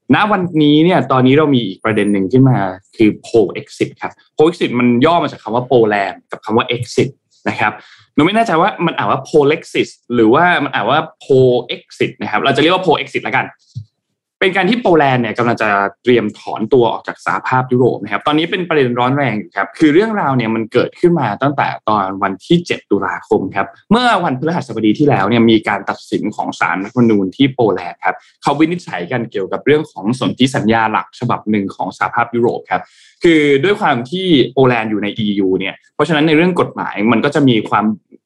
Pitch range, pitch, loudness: 110-155 Hz, 125 Hz, -14 LUFS